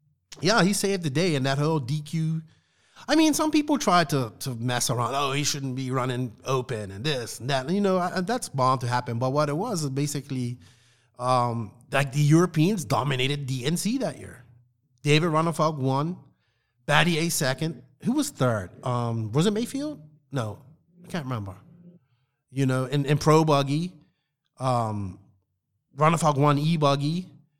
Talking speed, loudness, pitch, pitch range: 165 wpm, -25 LUFS, 145 Hz, 125-160 Hz